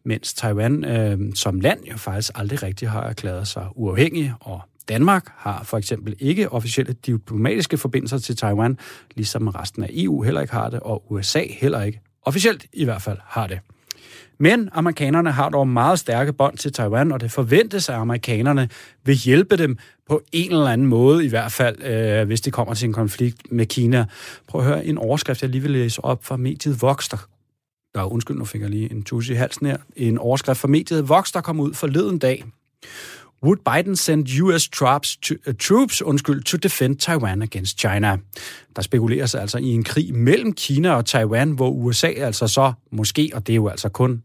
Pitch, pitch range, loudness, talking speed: 125 Hz, 110-145 Hz, -20 LUFS, 195 wpm